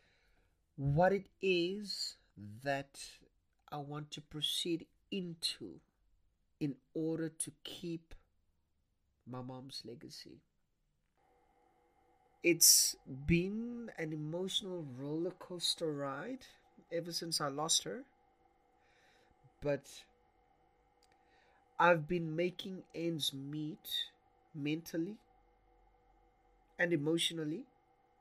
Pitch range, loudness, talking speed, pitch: 145-185 Hz, -36 LUFS, 80 wpm, 165 Hz